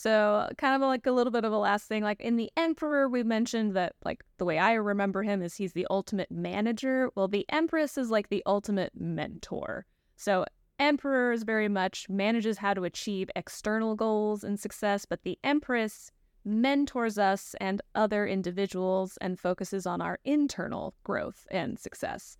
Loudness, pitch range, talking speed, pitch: -30 LUFS, 195-240 Hz, 175 wpm, 210 Hz